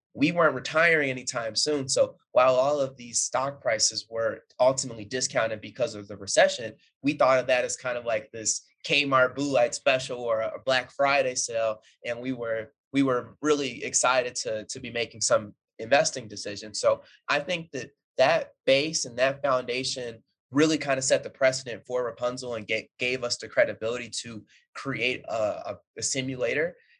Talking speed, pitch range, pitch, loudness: 180 wpm, 115-135 Hz, 125 Hz, -26 LUFS